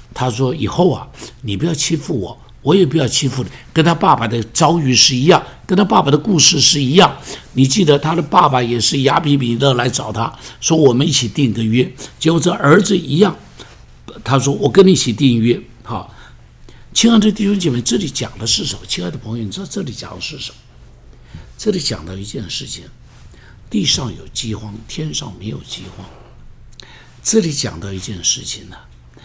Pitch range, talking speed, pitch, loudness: 115-165 Hz, 280 characters per minute, 135 Hz, -15 LUFS